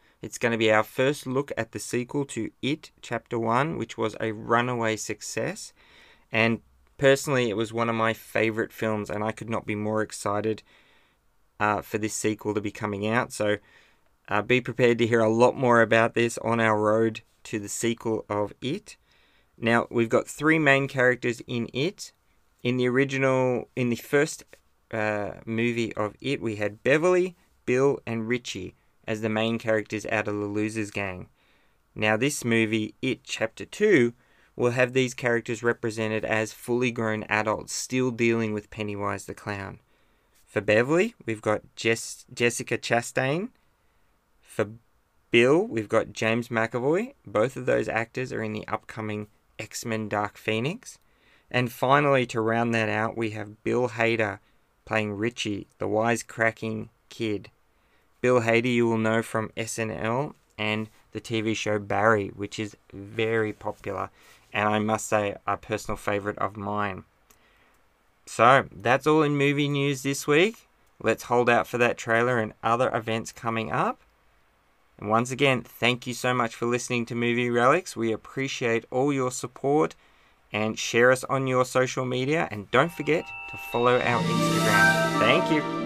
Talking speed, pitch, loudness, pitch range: 165 wpm, 115 Hz, -26 LUFS, 110-125 Hz